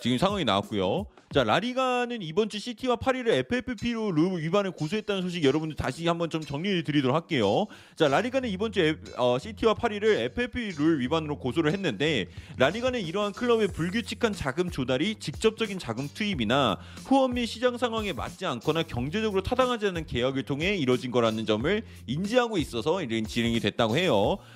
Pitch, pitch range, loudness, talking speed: 190 Hz, 140-230 Hz, -27 LUFS, 410 characters per minute